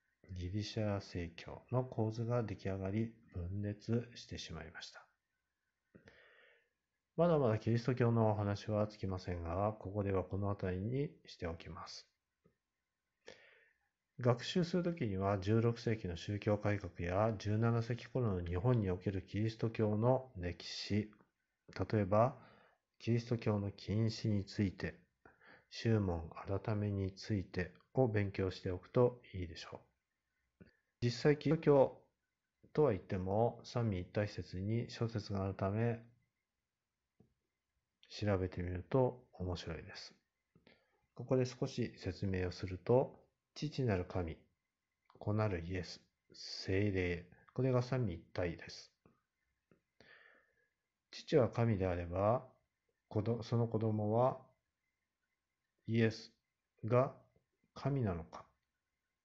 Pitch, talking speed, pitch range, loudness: 105 Hz, 220 characters per minute, 95-120 Hz, -38 LUFS